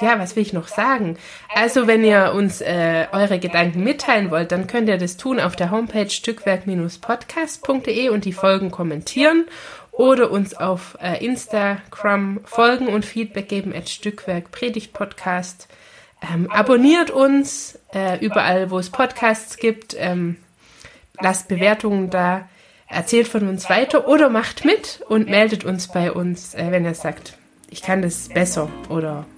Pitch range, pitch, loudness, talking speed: 180-230 Hz, 200 Hz, -19 LUFS, 150 wpm